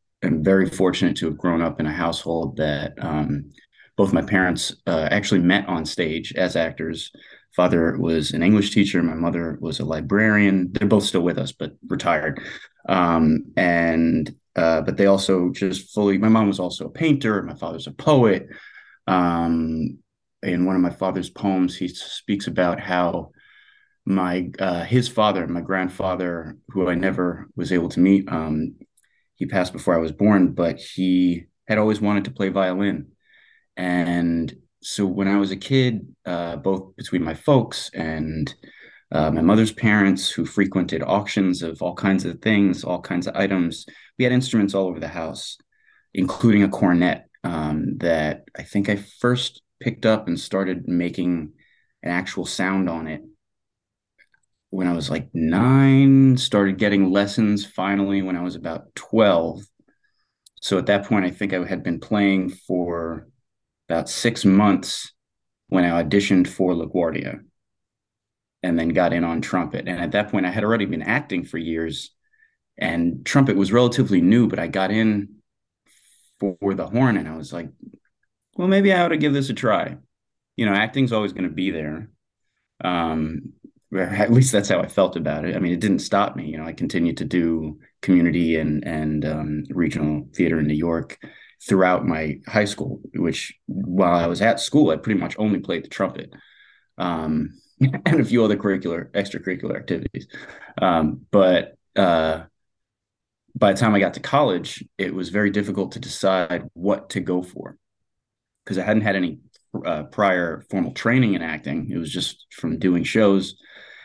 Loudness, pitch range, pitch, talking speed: -21 LUFS, 85-105 Hz, 95 Hz, 170 wpm